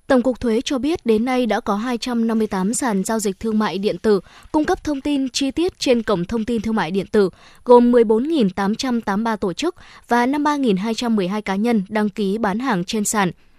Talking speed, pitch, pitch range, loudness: 200 wpm, 225 Hz, 205-250 Hz, -19 LUFS